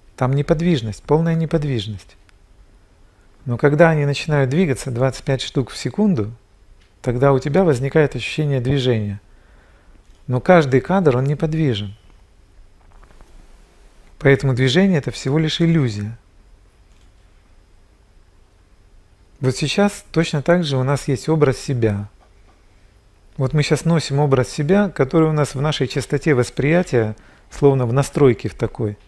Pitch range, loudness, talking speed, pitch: 100-150 Hz, -18 LUFS, 120 wpm, 130 Hz